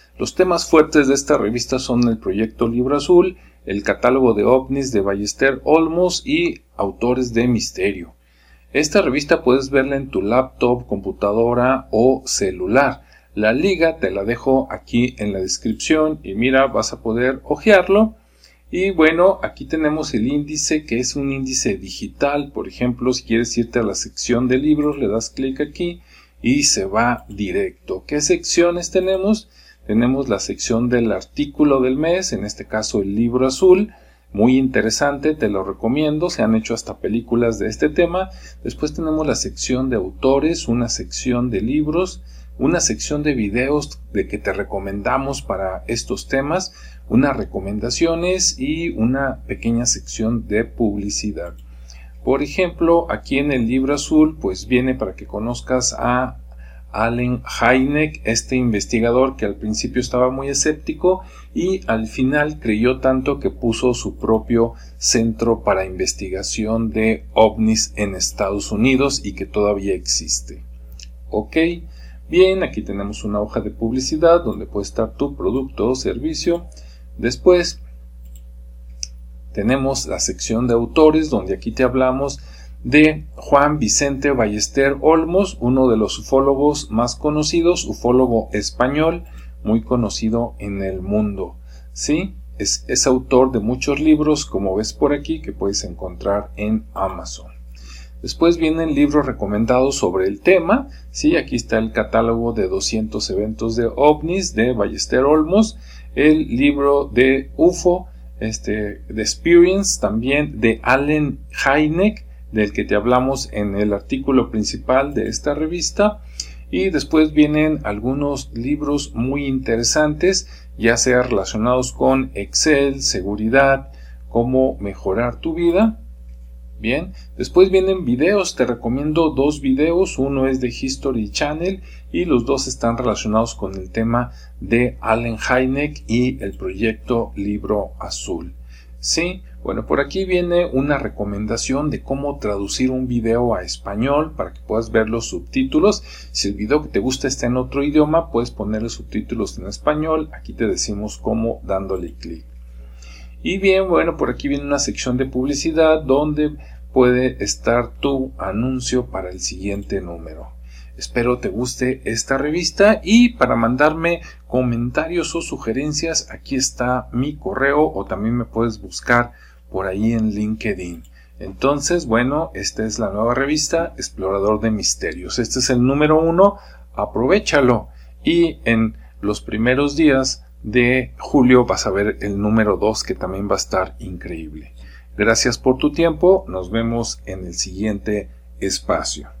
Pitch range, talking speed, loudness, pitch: 100-145 Hz, 145 wpm, -18 LUFS, 120 Hz